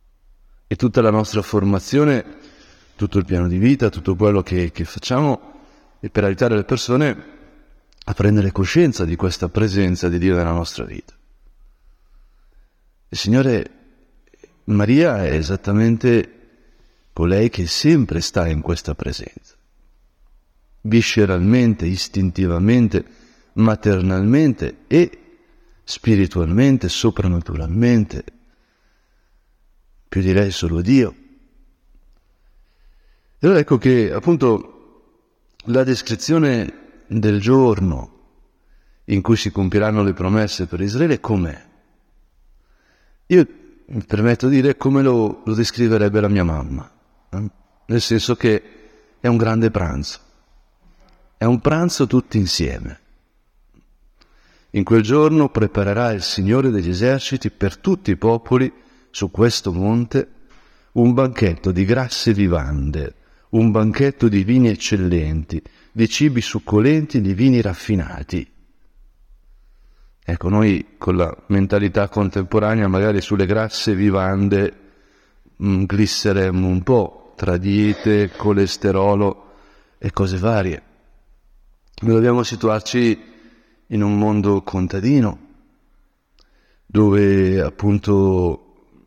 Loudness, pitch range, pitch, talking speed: -18 LUFS, 90-115 Hz, 105 Hz, 105 wpm